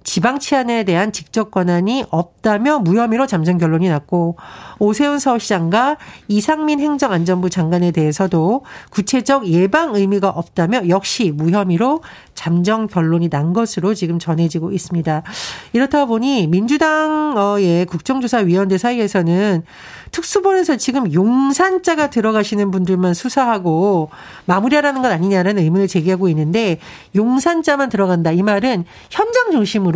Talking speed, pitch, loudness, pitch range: 335 characters per minute, 200 Hz, -16 LUFS, 175-260 Hz